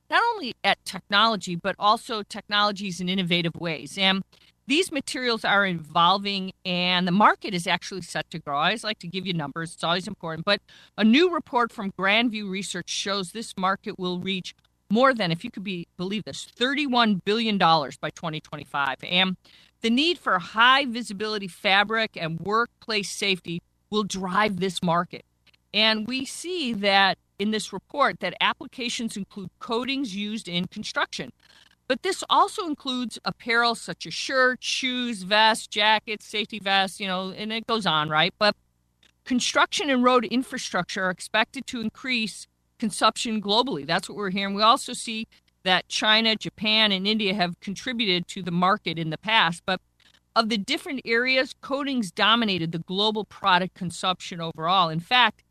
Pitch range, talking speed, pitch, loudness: 180-230 Hz, 160 wpm, 205 Hz, -24 LUFS